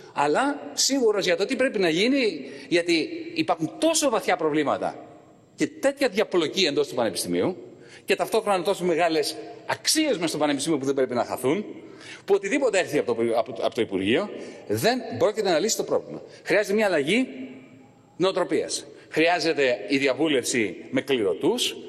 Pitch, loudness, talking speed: 200 Hz, -24 LUFS, 145 wpm